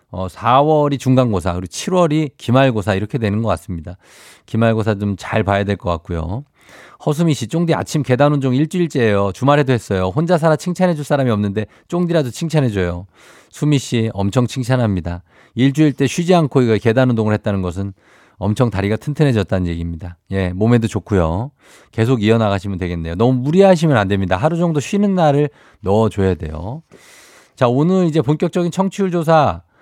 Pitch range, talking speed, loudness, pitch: 100-150 Hz, 380 characters per minute, -17 LUFS, 120 Hz